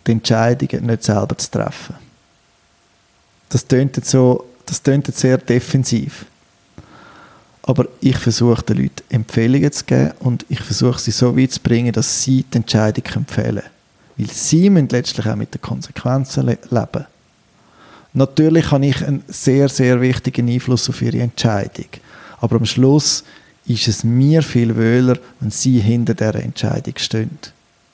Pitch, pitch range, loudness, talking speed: 125 Hz, 115-135 Hz, -16 LUFS, 140 wpm